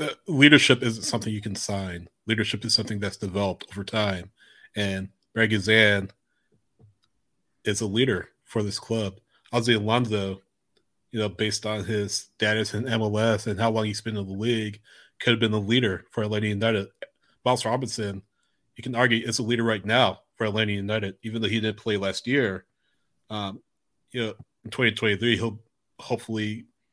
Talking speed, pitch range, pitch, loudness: 175 wpm, 105-115 Hz, 110 Hz, -25 LUFS